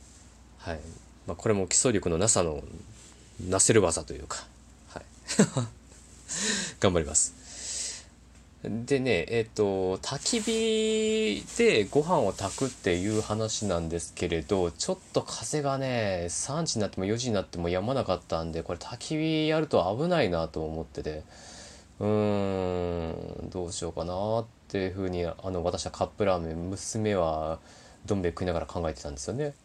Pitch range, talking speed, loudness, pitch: 85-115 Hz, 300 characters per minute, -29 LUFS, 95 Hz